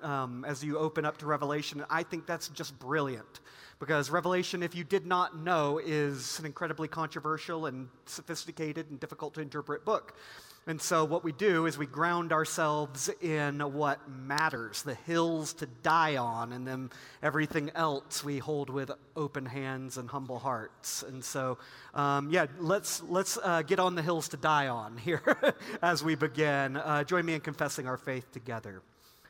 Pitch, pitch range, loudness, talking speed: 155 Hz, 140-165 Hz, -32 LUFS, 175 wpm